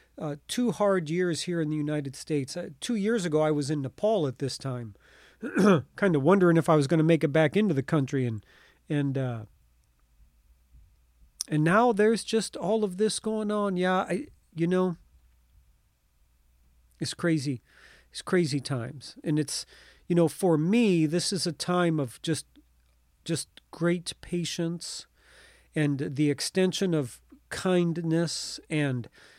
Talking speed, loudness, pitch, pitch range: 155 wpm, -27 LUFS, 155 Hz, 130-180 Hz